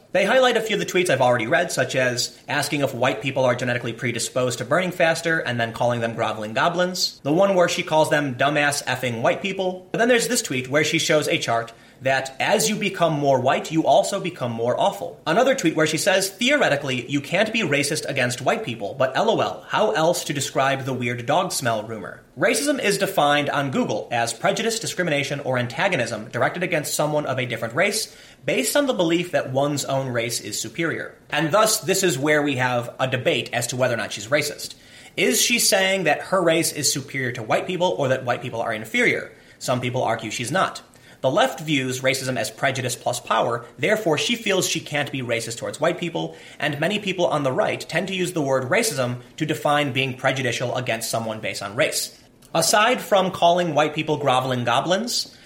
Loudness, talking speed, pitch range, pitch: -21 LUFS, 210 wpm, 125-180 Hz, 145 Hz